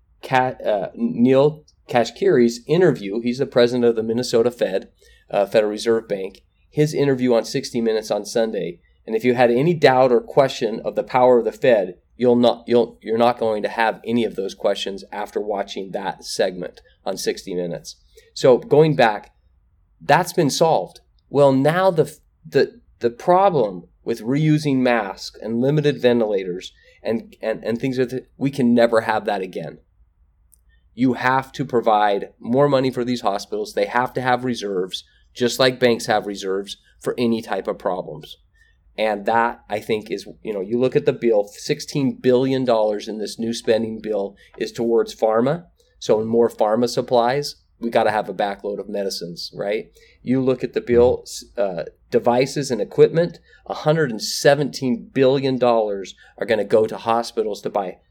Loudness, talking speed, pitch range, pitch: -20 LUFS, 165 wpm, 115-135 Hz, 120 Hz